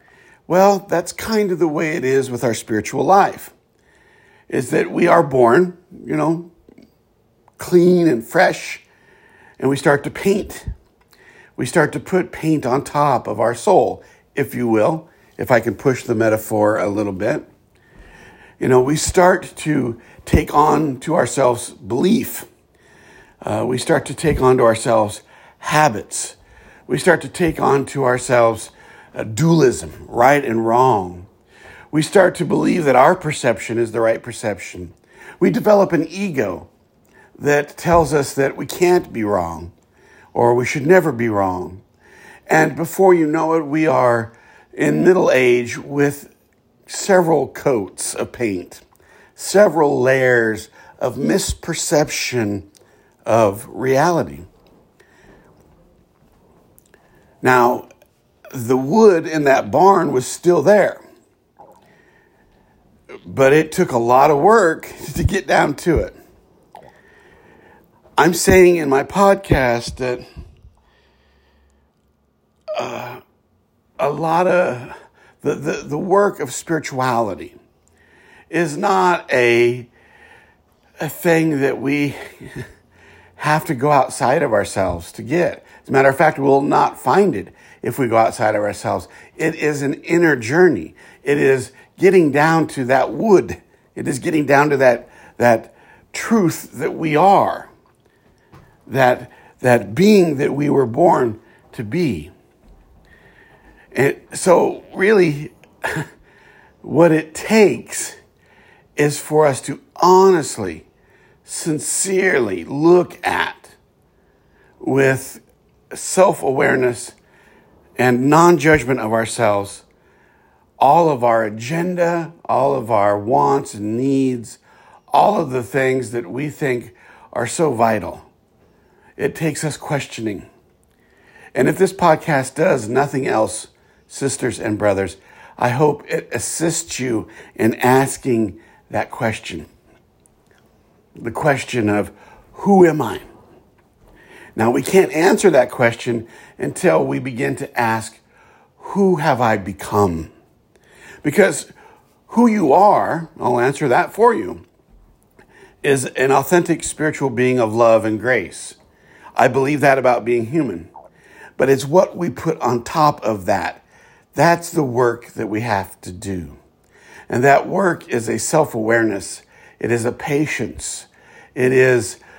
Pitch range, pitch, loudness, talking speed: 115-160 Hz, 135 Hz, -17 LUFS, 130 wpm